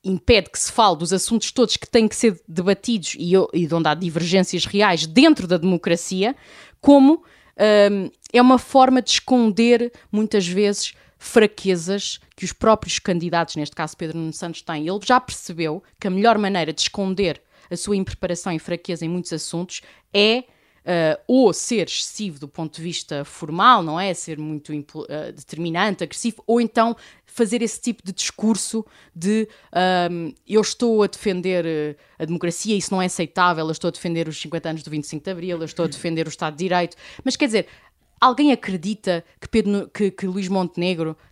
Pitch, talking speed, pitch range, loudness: 185 Hz, 180 wpm, 165-215 Hz, -20 LUFS